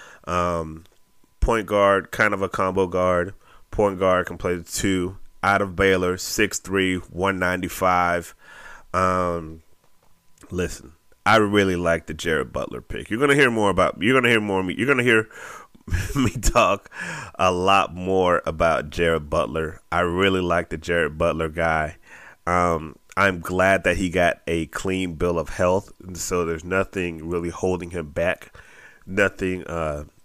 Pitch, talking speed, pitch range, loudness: 90 Hz, 160 wpm, 85-95 Hz, -22 LUFS